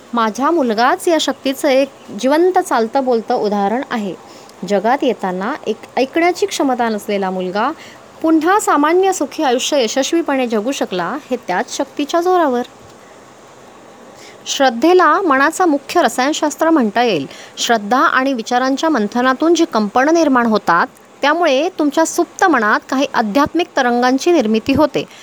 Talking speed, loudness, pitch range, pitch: 120 wpm, -15 LUFS, 240-320 Hz, 270 Hz